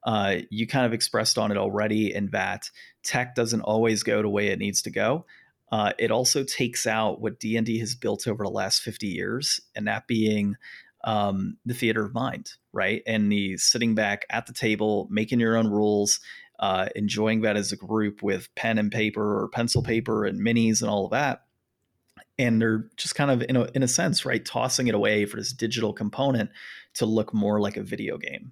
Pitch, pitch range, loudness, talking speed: 110 Hz, 105-115 Hz, -25 LUFS, 205 wpm